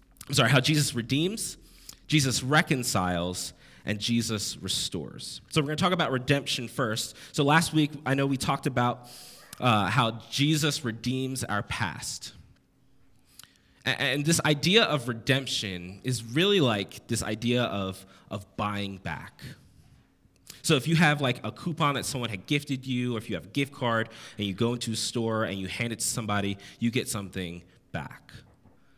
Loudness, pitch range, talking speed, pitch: -27 LUFS, 110-145 Hz, 170 wpm, 125 Hz